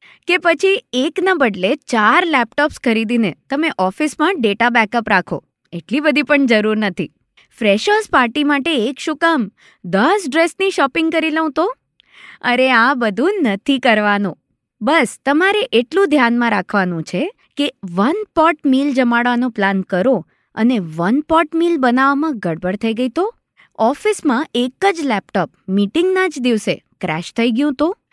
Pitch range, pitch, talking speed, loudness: 215-320 Hz, 260 Hz, 145 wpm, -16 LUFS